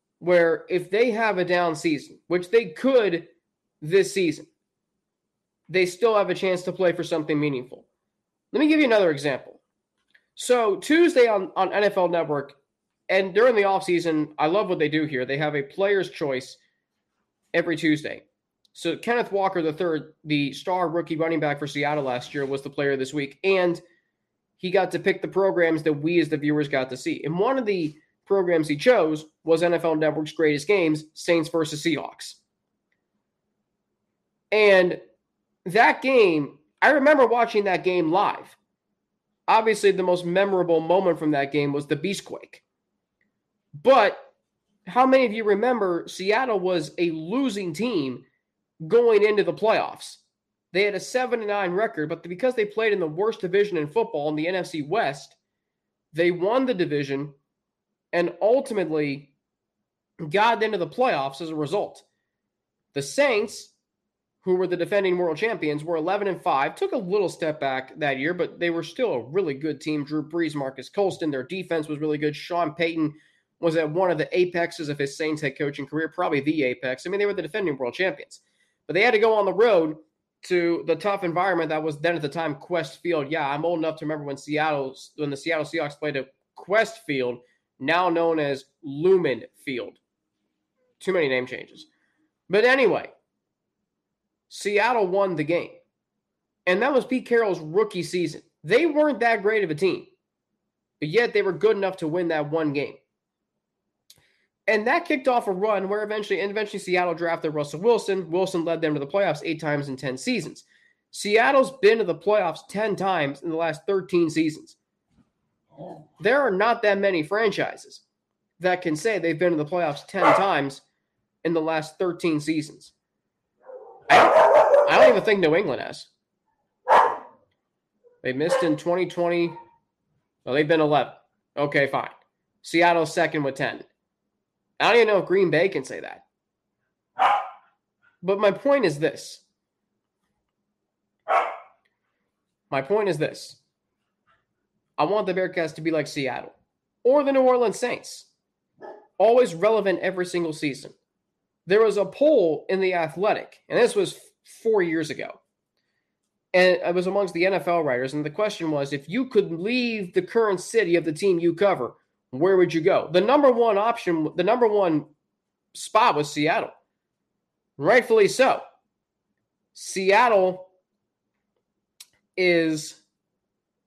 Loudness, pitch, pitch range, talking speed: -23 LUFS, 175 Hz, 155-210 Hz, 165 wpm